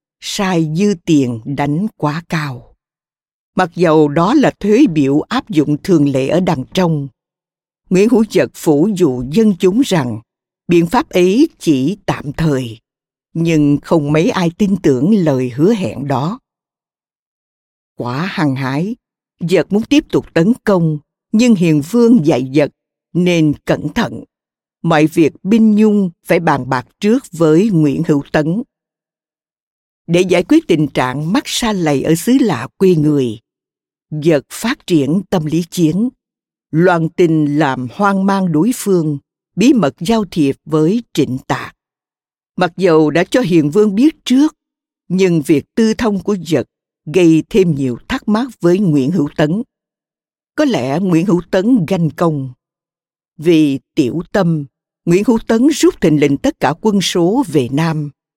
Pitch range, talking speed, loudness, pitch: 150-205 Hz, 155 wpm, -14 LUFS, 170 Hz